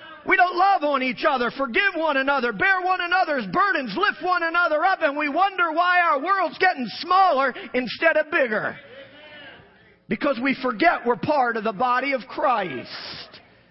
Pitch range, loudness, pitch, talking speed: 270-360 Hz, -21 LUFS, 315 Hz, 165 wpm